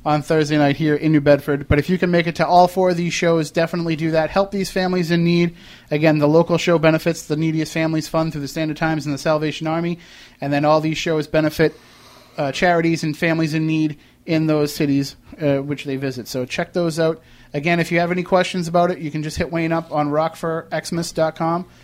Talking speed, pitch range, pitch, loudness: 230 wpm, 150-170 Hz, 160 Hz, -19 LUFS